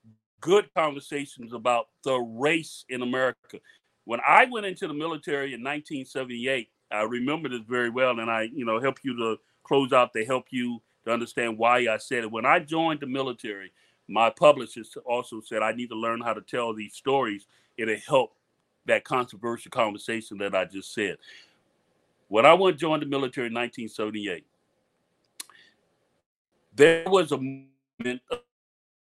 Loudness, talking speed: -26 LUFS, 160 wpm